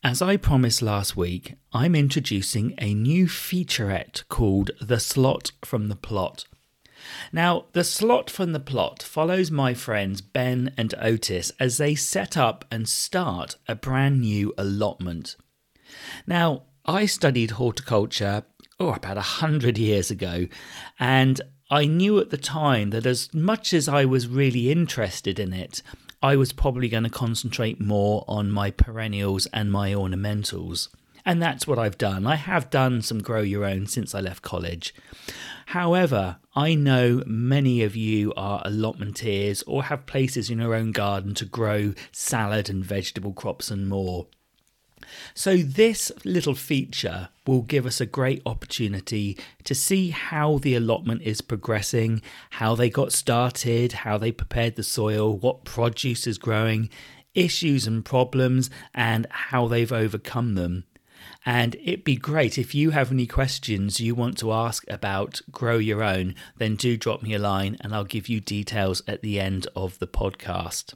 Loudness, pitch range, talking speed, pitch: -24 LUFS, 105-135 Hz, 160 wpm, 115 Hz